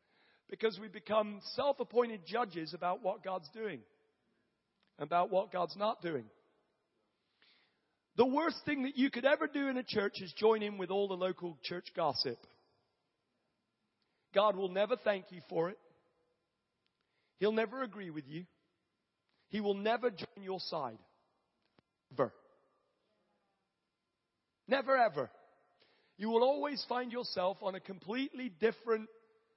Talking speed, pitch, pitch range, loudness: 130 wpm, 210 Hz, 185-235 Hz, -36 LUFS